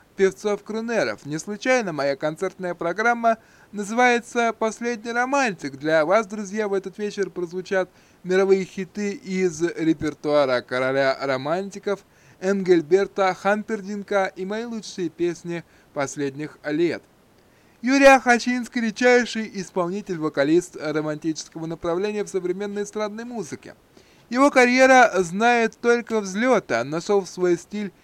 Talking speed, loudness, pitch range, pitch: 110 wpm, -22 LUFS, 170-225 Hz, 195 Hz